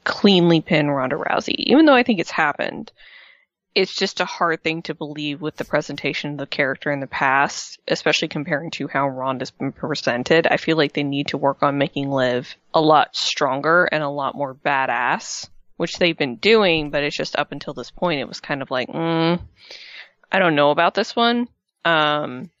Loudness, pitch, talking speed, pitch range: -20 LUFS, 150 Hz, 200 wpm, 140-170 Hz